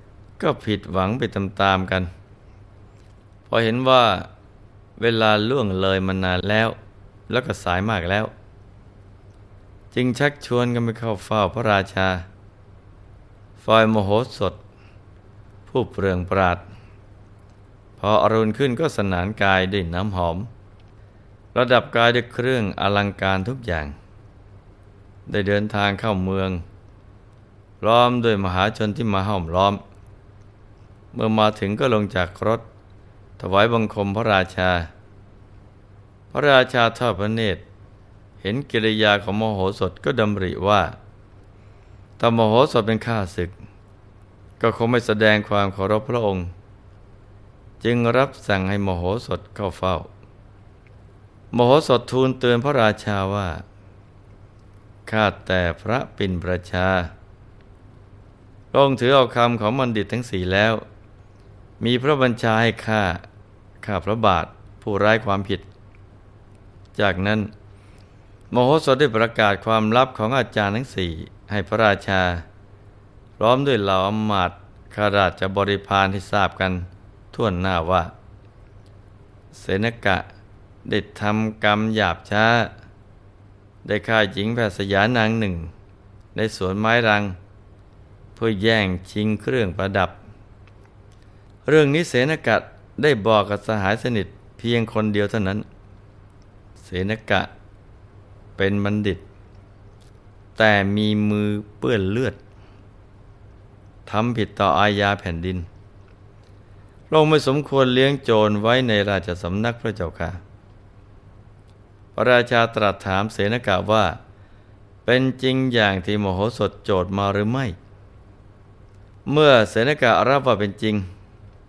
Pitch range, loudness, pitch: 100-110 Hz, -20 LUFS, 100 Hz